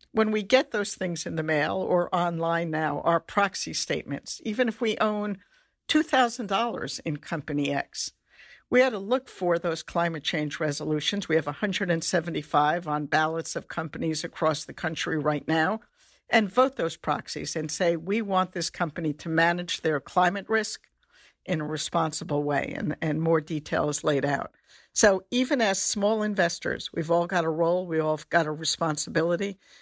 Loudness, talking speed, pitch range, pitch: -26 LUFS, 170 wpm, 155-205 Hz, 170 Hz